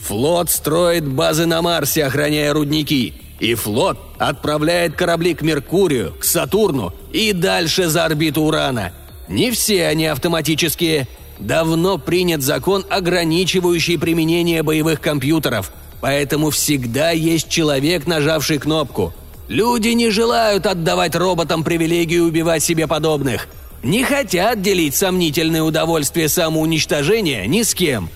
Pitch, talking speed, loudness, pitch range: 165 Hz, 115 wpm, -17 LUFS, 150-175 Hz